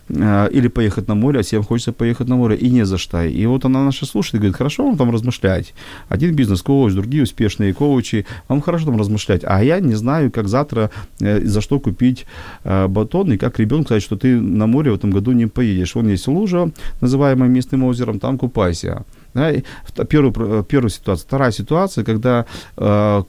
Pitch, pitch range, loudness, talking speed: 115 Hz, 105-130 Hz, -17 LUFS, 190 wpm